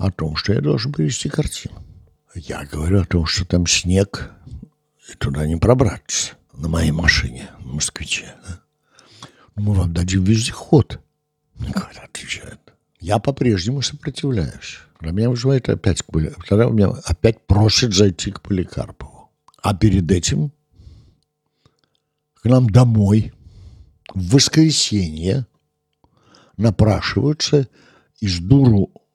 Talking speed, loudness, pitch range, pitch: 115 wpm, -18 LUFS, 85-120 Hz, 100 Hz